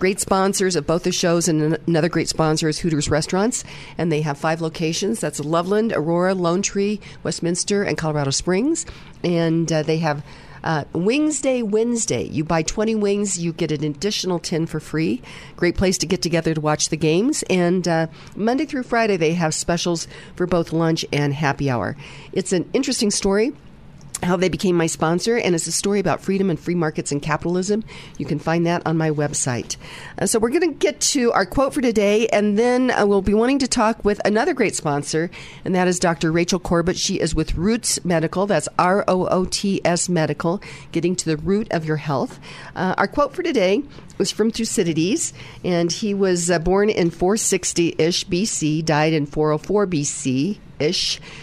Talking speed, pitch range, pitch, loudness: 195 wpm, 155-200 Hz, 170 Hz, -20 LUFS